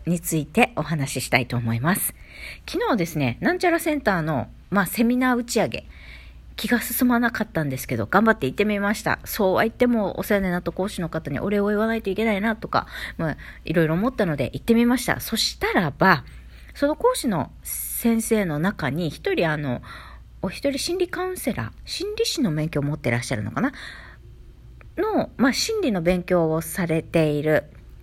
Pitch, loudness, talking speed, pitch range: 190 Hz, -23 LUFS, 380 characters per minute, 150-235 Hz